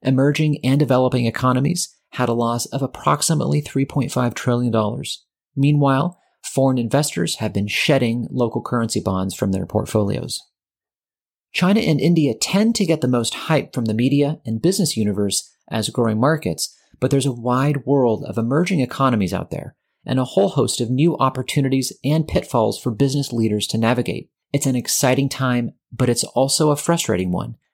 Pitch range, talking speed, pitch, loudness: 115-145 Hz, 160 wpm, 130 Hz, -20 LUFS